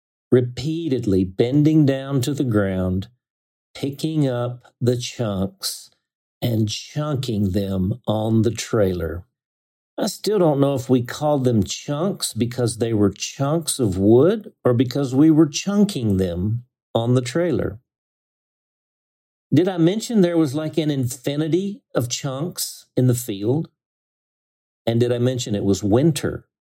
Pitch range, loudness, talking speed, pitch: 105-150 Hz, -21 LUFS, 135 wpm, 125 Hz